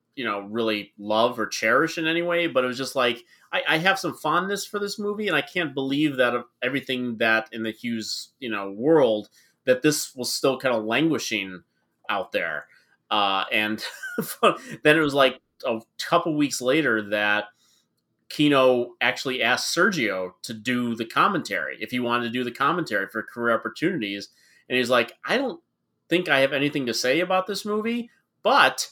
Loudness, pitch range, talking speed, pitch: -24 LUFS, 110-155 Hz, 185 wpm, 125 Hz